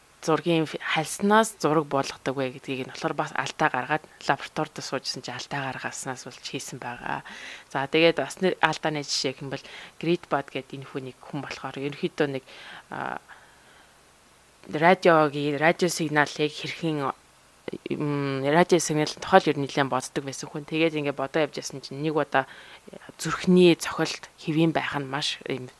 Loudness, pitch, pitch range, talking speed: -26 LUFS, 150 Hz, 135-160 Hz, 150 wpm